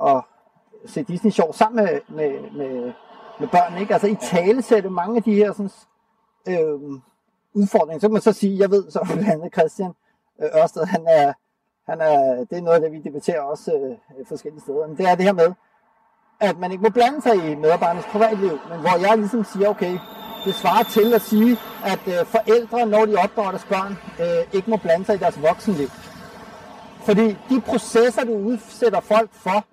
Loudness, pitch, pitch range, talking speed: -20 LUFS, 215 Hz, 180-225 Hz, 190 wpm